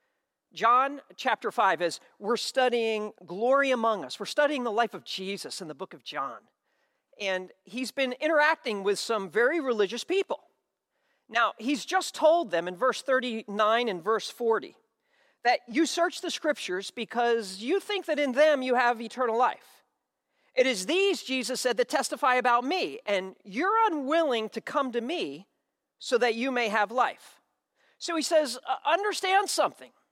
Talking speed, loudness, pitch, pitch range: 165 wpm, -27 LUFS, 250 Hz, 225-310 Hz